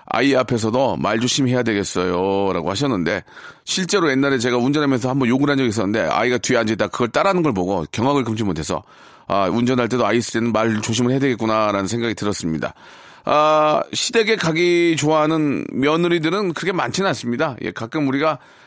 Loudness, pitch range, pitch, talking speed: -19 LUFS, 110-150 Hz, 125 Hz, 420 characters per minute